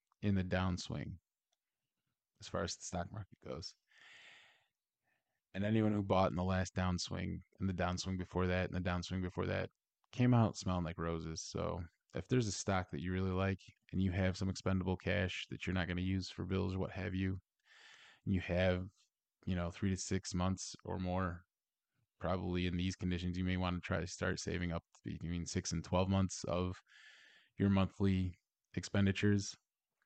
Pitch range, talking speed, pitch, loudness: 90-95 Hz, 185 wpm, 95 Hz, -38 LUFS